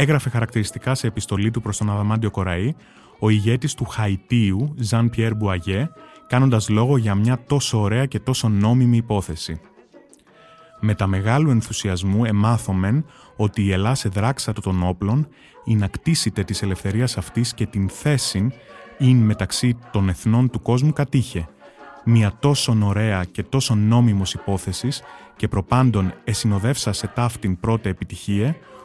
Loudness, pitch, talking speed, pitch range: -21 LUFS, 110 Hz, 140 wpm, 100-130 Hz